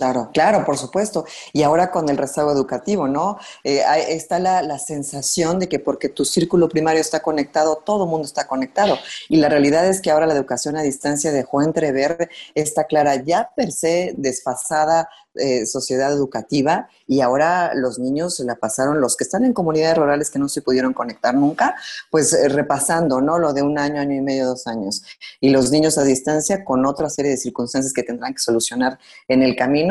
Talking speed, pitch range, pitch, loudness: 195 wpm, 135-160 Hz, 145 Hz, -19 LUFS